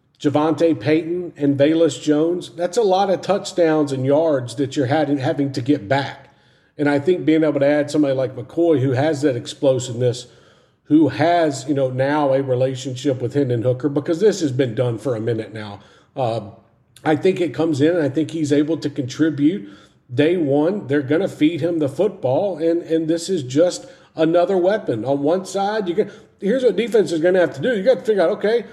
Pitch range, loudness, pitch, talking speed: 135-170 Hz, -19 LUFS, 150 Hz, 210 wpm